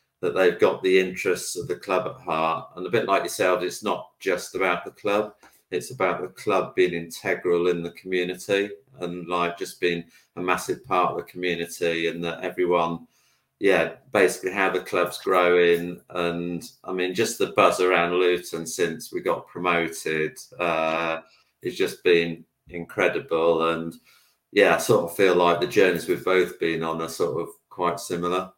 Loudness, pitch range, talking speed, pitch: -24 LUFS, 85-90 Hz, 180 wpm, 90 Hz